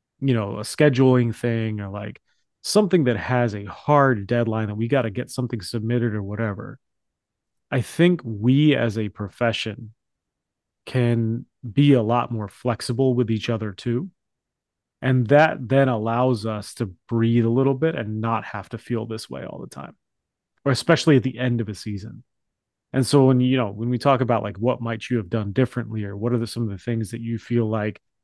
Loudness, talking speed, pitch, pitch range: -22 LUFS, 200 wpm, 120 Hz, 110-130 Hz